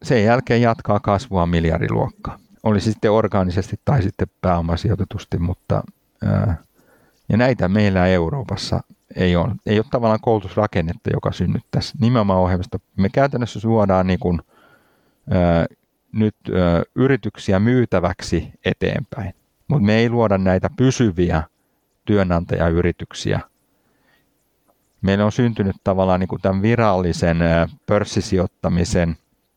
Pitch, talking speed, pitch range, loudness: 100 Hz, 110 wpm, 90-110 Hz, -19 LUFS